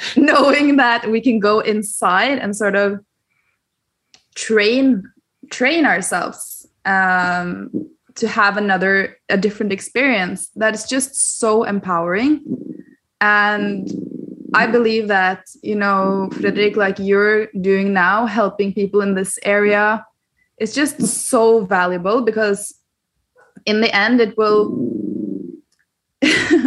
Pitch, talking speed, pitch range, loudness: 215 Hz, 110 wpm, 200-250 Hz, -16 LUFS